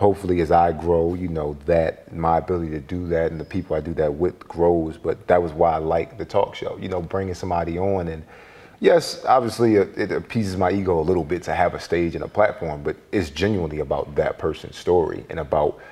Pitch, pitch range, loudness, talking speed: 85 Hz, 80-90 Hz, -22 LUFS, 230 wpm